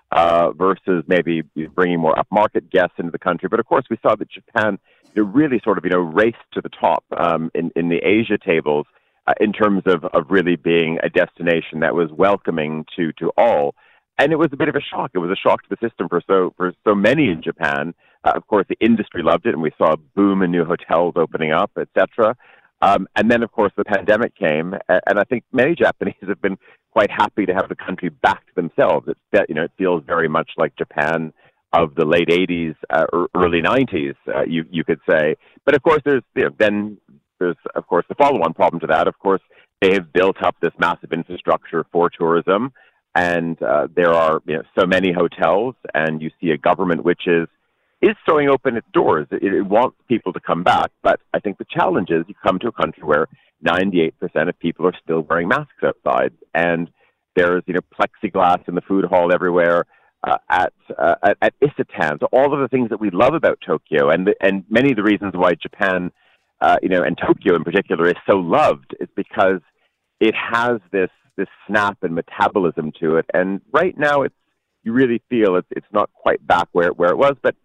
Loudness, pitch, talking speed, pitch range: -18 LUFS, 90 Hz, 215 wpm, 85-105 Hz